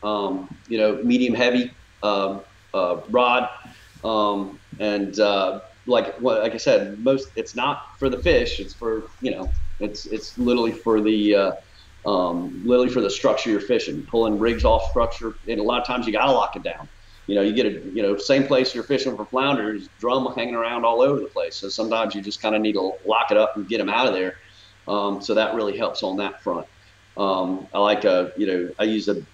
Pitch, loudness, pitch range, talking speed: 105 Hz, -22 LUFS, 100-115 Hz, 220 wpm